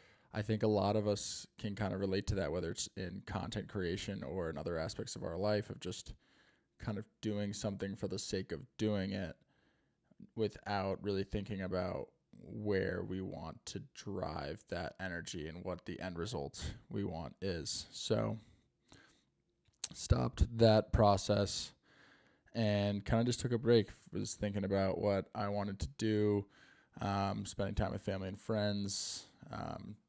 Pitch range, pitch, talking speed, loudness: 95-105 Hz, 100 Hz, 165 wpm, -38 LUFS